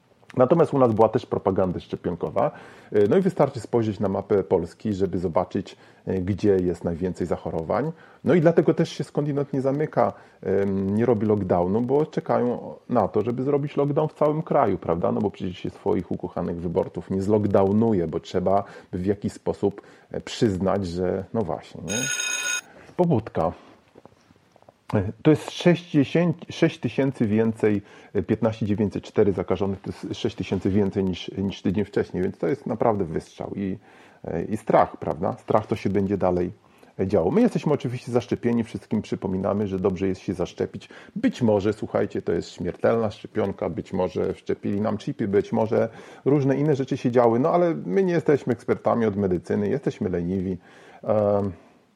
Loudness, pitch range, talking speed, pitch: -24 LUFS, 100-145 Hz, 155 wpm, 110 Hz